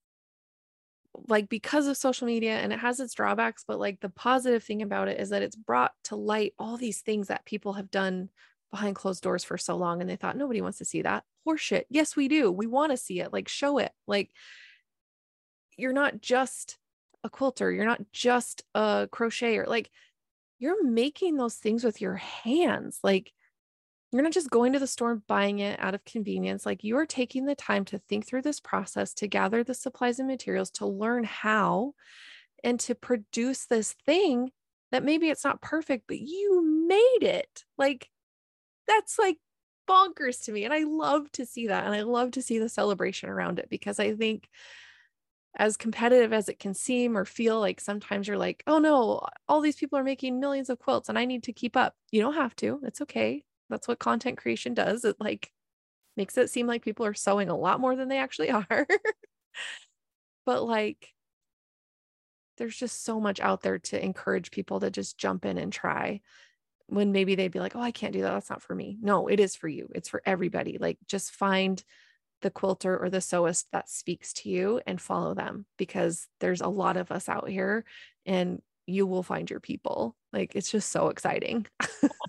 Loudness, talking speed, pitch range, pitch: -29 LUFS, 200 wpm, 200-265 Hz, 230 Hz